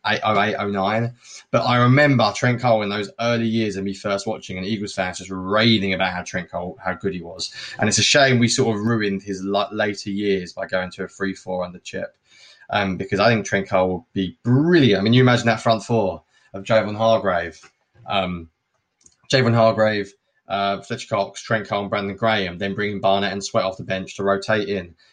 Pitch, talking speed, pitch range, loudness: 100 Hz, 210 wpm, 95-115 Hz, -20 LUFS